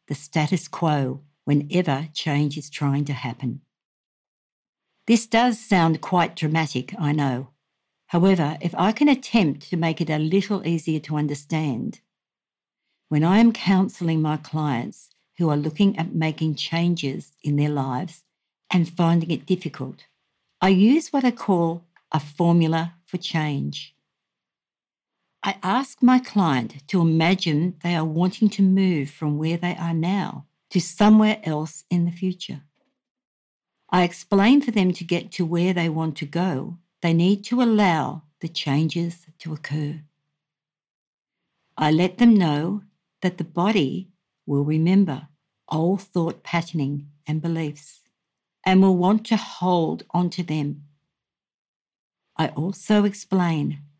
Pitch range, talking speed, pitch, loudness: 150-185 Hz, 140 wpm, 165 Hz, -22 LUFS